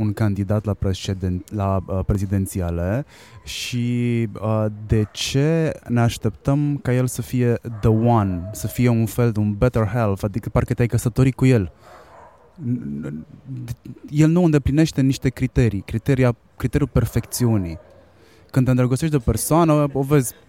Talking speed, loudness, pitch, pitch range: 145 wpm, -21 LUFS, 115 Hz, 105-130 Hz